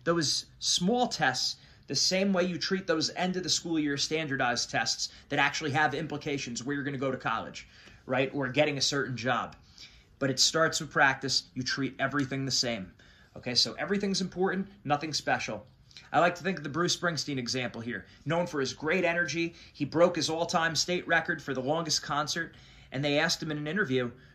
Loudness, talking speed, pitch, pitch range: -29 LUFS, 200 wpm, 150 Hz, 130-170 Hz